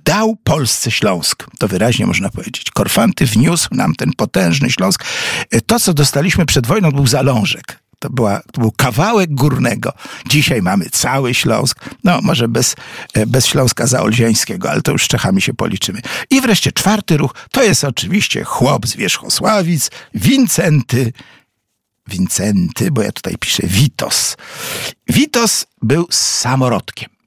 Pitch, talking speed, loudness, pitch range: 140 Hz, 140 wpm, -14 LUFS, 120-185 Hz